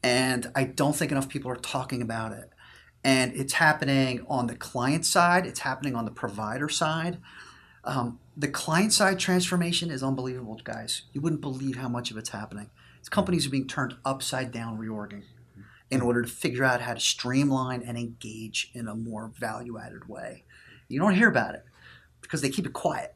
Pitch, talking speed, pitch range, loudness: 130 Hz, 190 wpm, 115-140 Hz, -27 LUFS